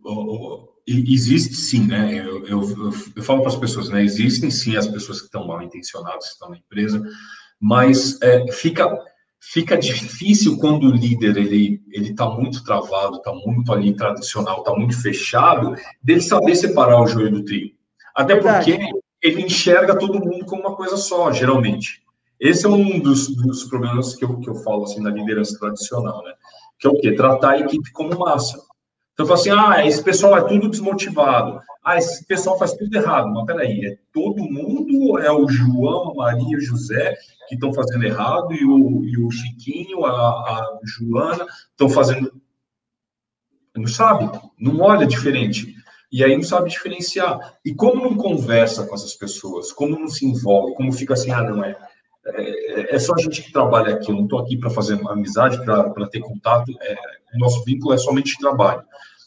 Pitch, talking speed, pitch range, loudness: 130 Hz, 185 wpm, 110-160 Hz, -18 LUFS